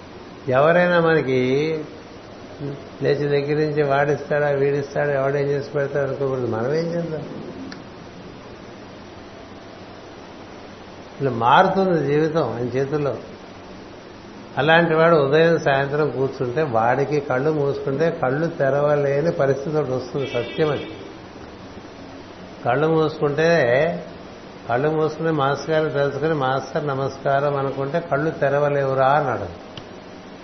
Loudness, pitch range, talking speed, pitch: -20 LUFS, 130-155 Hz, 85 wpm, 140 Hz